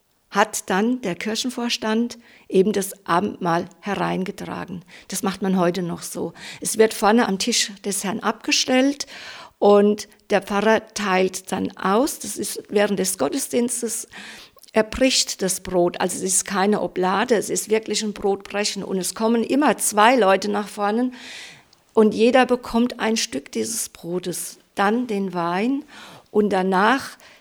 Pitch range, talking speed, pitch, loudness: 190-230 Hz, 145 wpm, 210 Hz, -21 LUFS